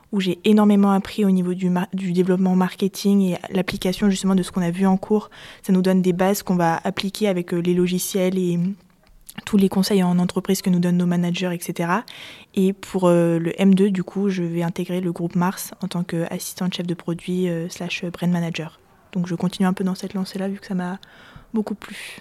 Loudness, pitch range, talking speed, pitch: -21 LUFS, 175-195 Hz, 220 wpm, 185 Hz